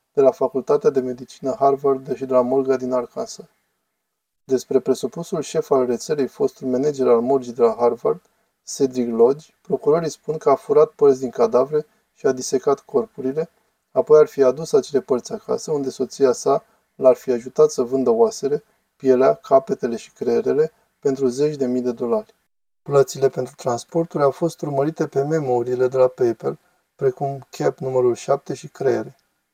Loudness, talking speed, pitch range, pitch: -20 LUFS, 165 wpm, 130-220 Hz, 150 Hz